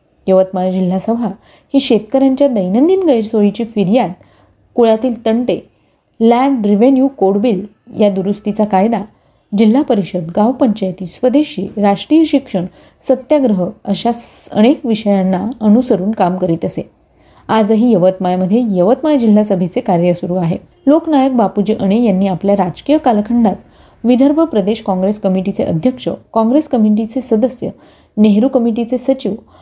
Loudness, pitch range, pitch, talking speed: -13 LUFS, 195-250 Hz, 220 Hz, 115 wpm